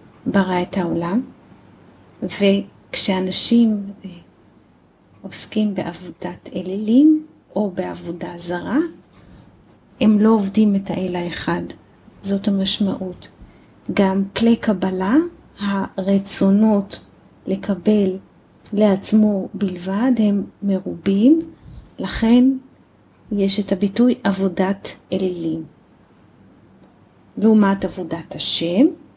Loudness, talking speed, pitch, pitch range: -19 LUFS, 75 wpm, 195 Hz, 185-215 Hz